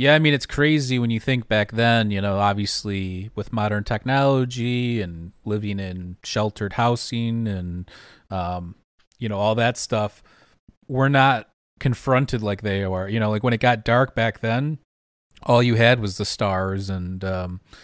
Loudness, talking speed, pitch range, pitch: -22 LUFS, 170 wpm, 100-120 Hz, 110 Hz